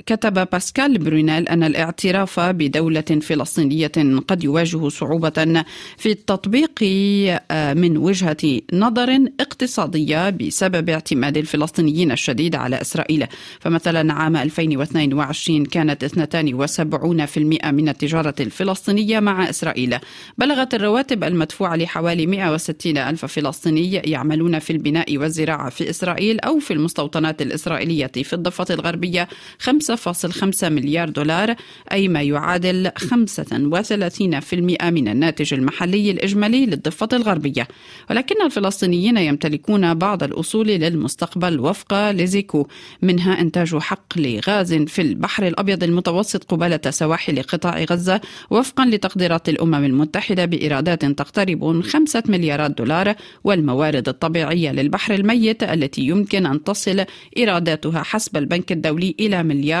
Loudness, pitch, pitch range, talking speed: -19 LUFS, 170 Hz, 155-195 Hz, 110 wpm